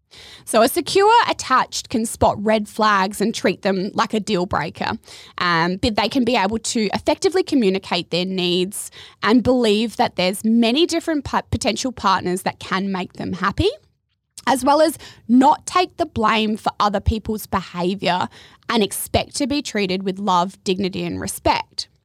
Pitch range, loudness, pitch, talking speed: 190-255 Hz, -19 LUFS, 215 Hz, 165 wpm